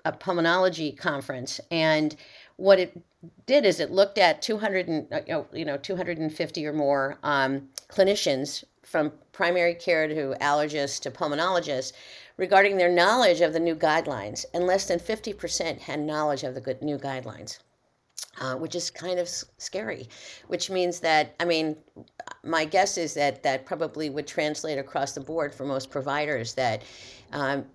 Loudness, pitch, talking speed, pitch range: -26 LUFS, 160 Hz, 160 wpm, 145-180 Hz